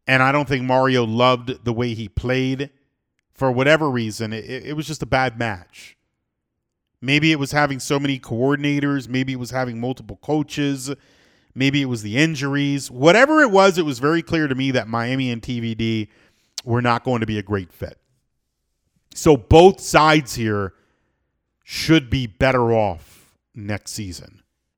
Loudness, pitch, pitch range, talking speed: -19 LUFS, 130 Hz, 115-140 Hz, 165 wpm